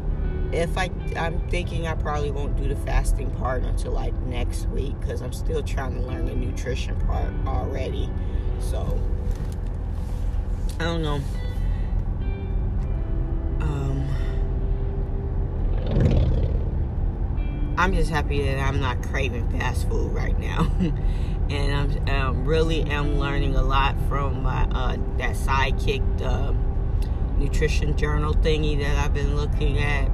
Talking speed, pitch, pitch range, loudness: 125 wpm, 85 Hz, 75-90 Hz, -26 LUFS